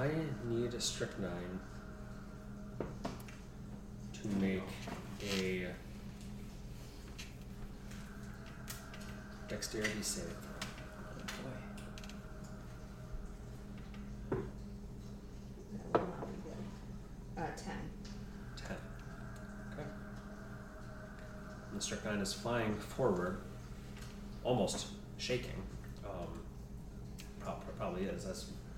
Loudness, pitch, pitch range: -43 LUFS, 65 Hz, 65-100 Hz